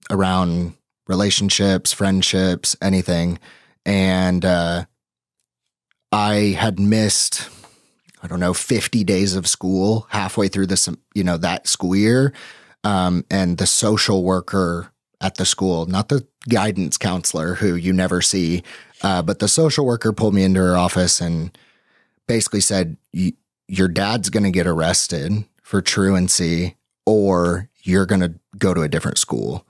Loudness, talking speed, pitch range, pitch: -18 LUFS, 135 wpm, 90-100 Hz, 95 Hz